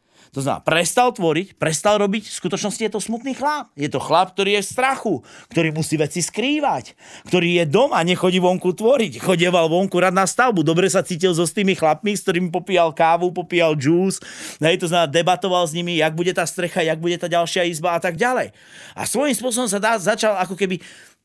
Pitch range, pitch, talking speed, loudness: 170-205 Hz, 180 Hz, 205 wpm, -19 LUFS